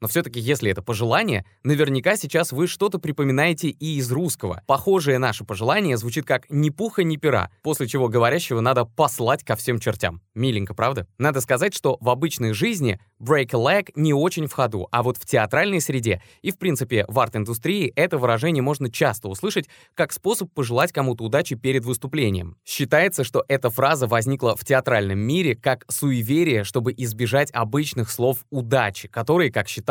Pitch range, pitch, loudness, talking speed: 115-150 Hz, 130 Hz, -22 LUFS, 170 wpm